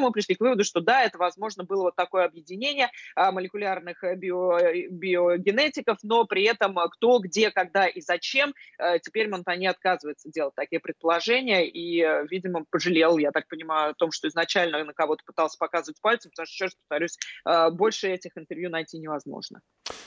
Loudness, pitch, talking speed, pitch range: -25 LUFS, 180 Hz, 160 wpm, 165-200 Hz